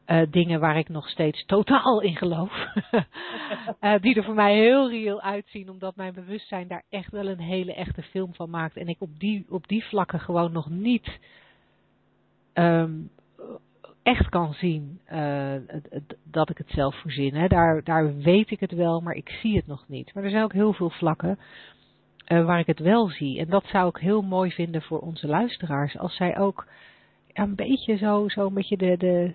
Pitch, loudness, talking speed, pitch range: 180 Hz, -25 LUFS, 195 wpm, 165-205 Hz